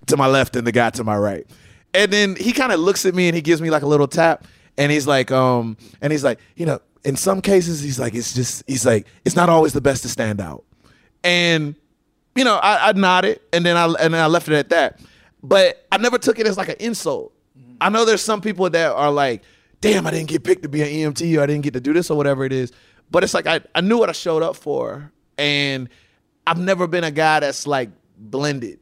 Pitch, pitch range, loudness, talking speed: 155 Hz, 135-185 Hz, -18 LUFS, 260 wpm